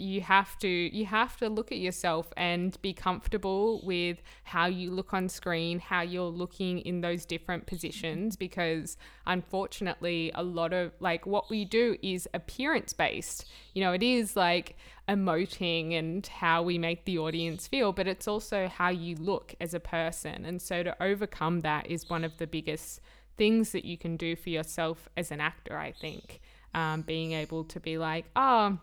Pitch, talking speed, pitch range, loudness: 175 Hz, 185 wpm, 165-190 Hz, -31 LUFS